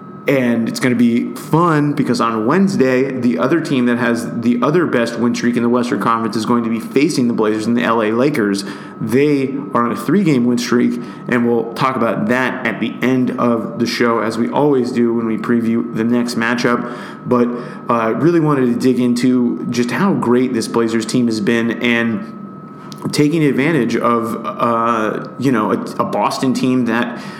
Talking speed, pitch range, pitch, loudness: 195 wpm, 115-130 Hz, 120 Hz, -16 LUFS